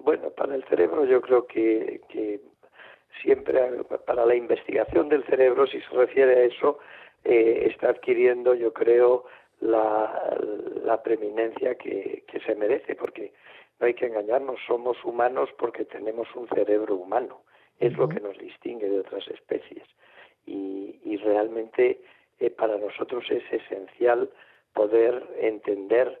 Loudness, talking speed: -25 LUFS, 140 wpm